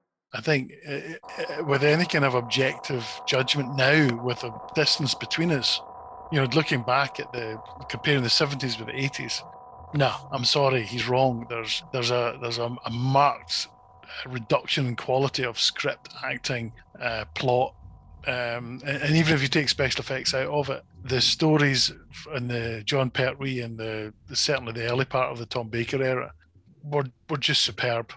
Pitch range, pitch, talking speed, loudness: 120-145 Hz, 130 Hz, 175 wpm, -25 LUFS